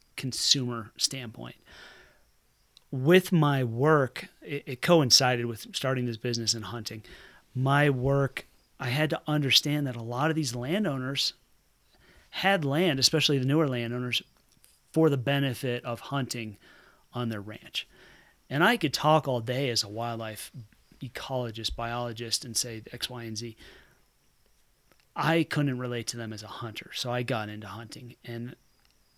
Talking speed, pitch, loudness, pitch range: 145 wpm, 125 Hz, -27 LUFS, 115-145 Hz